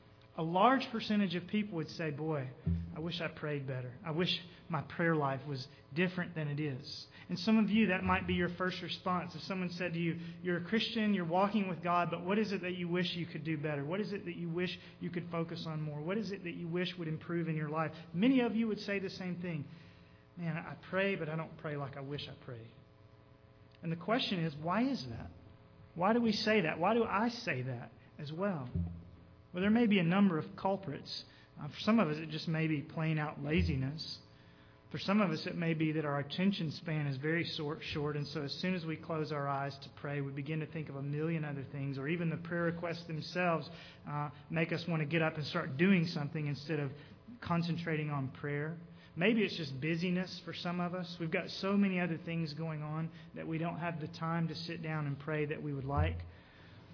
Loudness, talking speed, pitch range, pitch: -36 LUFS, 235 wpm, 150-180 Hz, 165 Hz